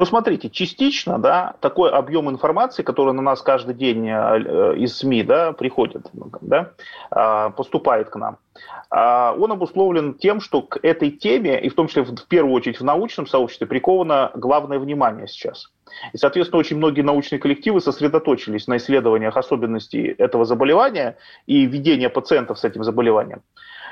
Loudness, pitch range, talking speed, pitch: -19 LUFS, 130-185 Hz, 150 wpm, 145 Hz